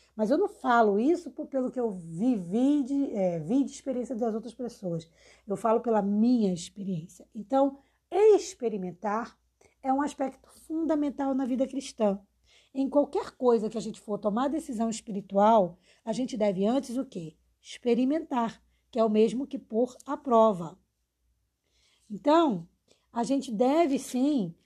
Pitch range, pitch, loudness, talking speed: 210-275 Hz, 235 Hz, -28 LUFS, 150 wpm